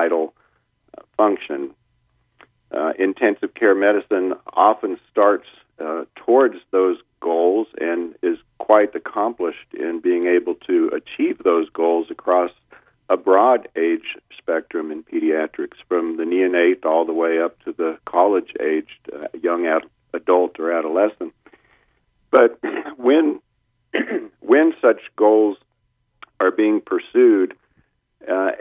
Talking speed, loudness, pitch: 115 wpm, -19 LUFS, 325 Hz